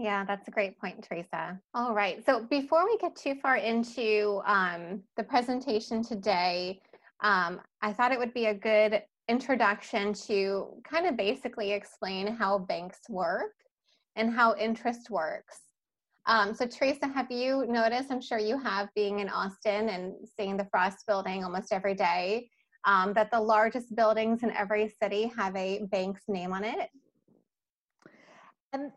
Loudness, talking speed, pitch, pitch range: -30 LUFS, 155 wpm, 215 Hz, 200-245 Hz